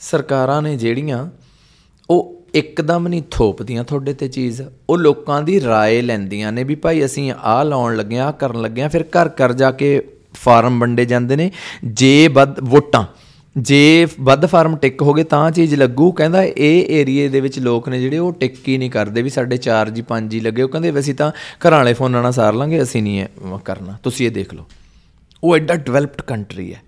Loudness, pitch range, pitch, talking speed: -15 LUFS, 120-150 Hz, 135 Hz, 200 wpm